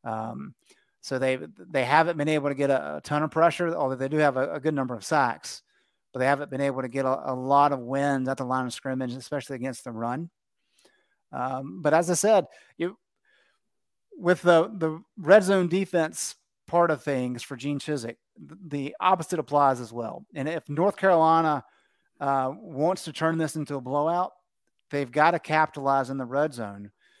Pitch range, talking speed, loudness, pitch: 130-165 Hz, 195 wpm, -26 LUFS, 145 Hz